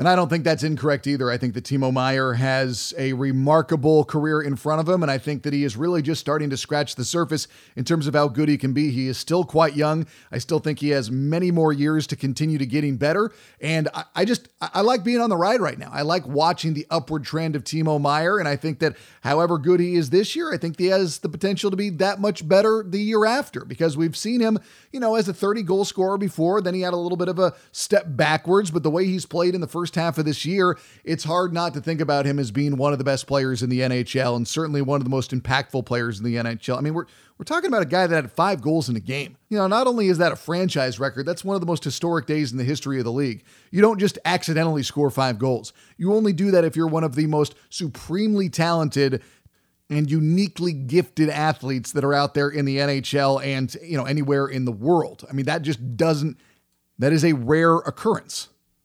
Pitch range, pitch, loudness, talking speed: 140-175 Hz, 155 Hz, -22 LUFS, 255 wpm